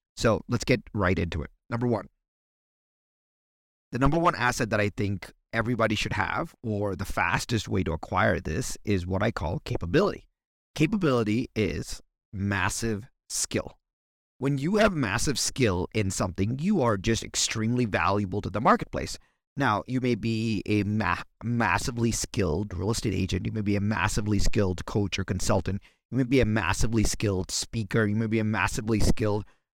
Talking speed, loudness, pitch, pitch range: 165 wpm, -27 LUFS, 110 Hz, 100-120 Hz